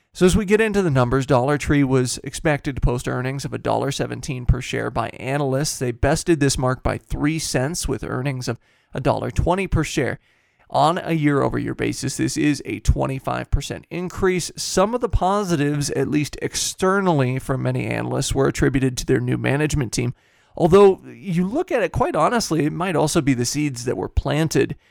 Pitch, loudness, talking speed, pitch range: 145 Hz, -21 LUFS, 185 wpm, 130-170 Hz